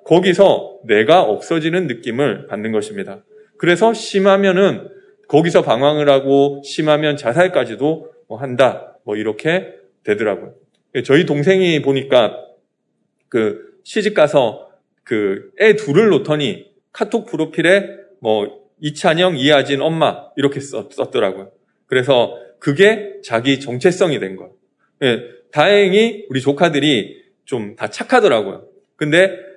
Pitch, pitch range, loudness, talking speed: 170 Hz, 140-200 Hz, -16 LUFS, 265 characters per minute